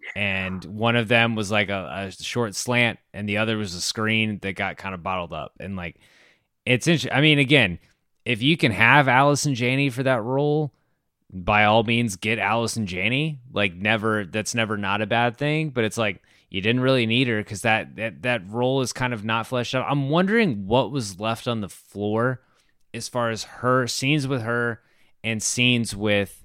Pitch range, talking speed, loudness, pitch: 105-130 Hz, 205 wpm, -22 LUFS, 115 Hz